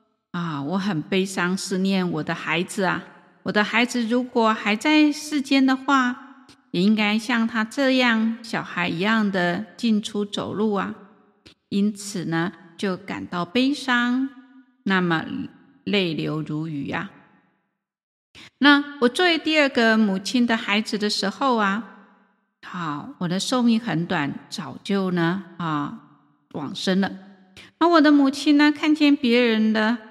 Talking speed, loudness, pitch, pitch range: 195 characters per minute, -22 LUFS, 215 Hz, 190-250 Hz